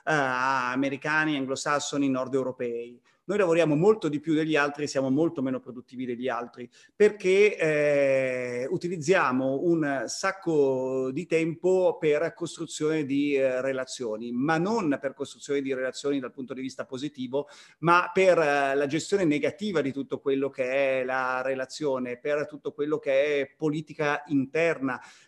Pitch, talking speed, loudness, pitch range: 140 Hz, 145 wpm, -26 LUFS, 130-160 Hz